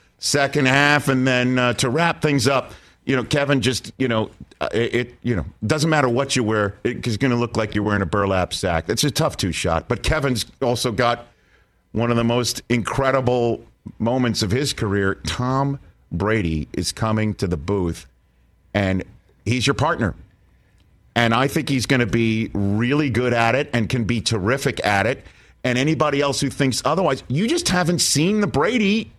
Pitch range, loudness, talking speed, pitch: 110-140 Hz, -20 LUFS, 190 wpm, 120 Hz